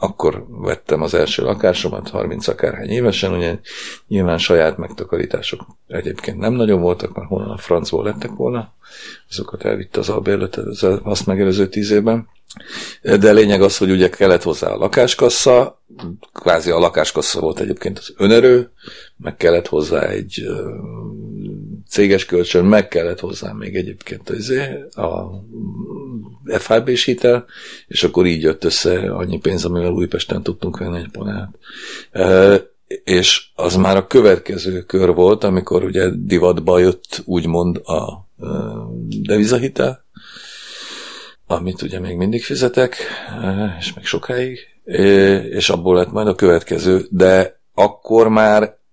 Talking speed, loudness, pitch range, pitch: 130 wpm, -16 LUFS, 90-110 Hz, 95 Hz